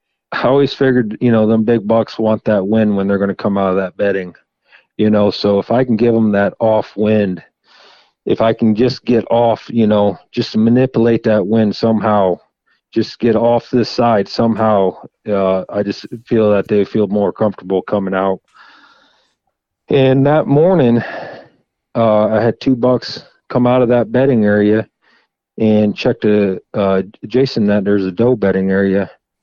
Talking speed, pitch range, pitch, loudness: 175 wpm, 100-120 Hz, 110 Hz, -14 LUFS